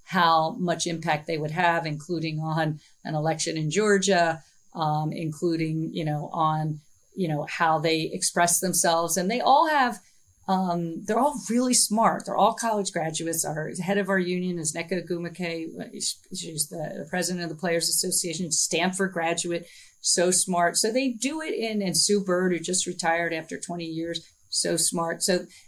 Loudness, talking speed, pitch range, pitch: -25 LUFS, 170 wpm, 160-185 Hz, 170 Hz